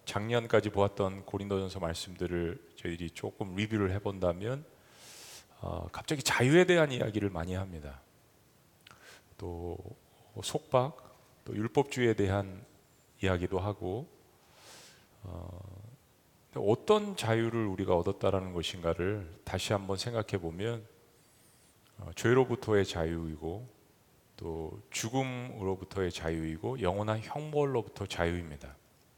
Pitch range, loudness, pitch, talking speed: 90-115 Hz, -33 LUFS, 100 Hz, 260 characters per minute